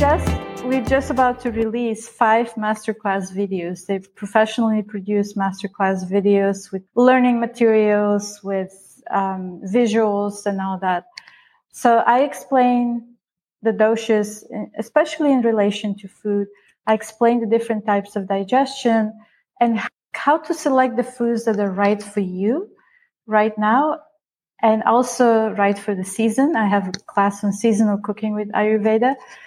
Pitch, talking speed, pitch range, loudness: 220 Hz, 140 wpm, 200-240 Hz, -19 LUFS